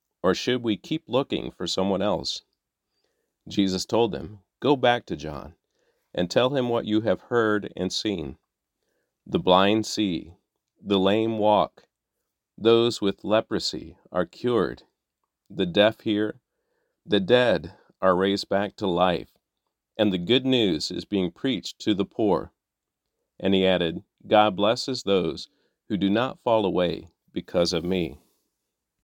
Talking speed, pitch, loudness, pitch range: 145 wpm, 105 Hz, -24 LUFS, 95-115 Hz